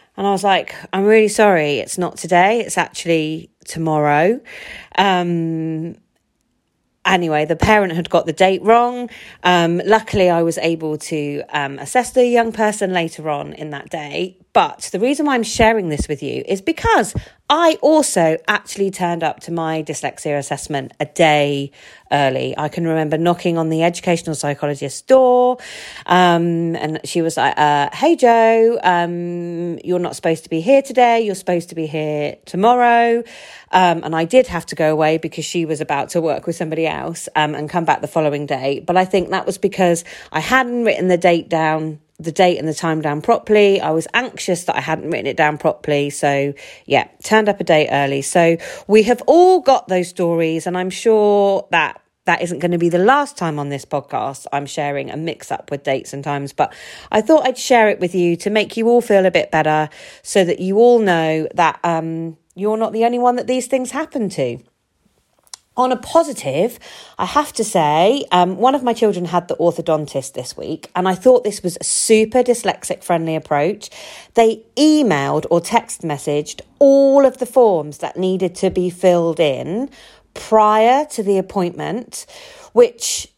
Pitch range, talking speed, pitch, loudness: 160-225 Hz, 190 wpm, 175 Hz, -17 LUFS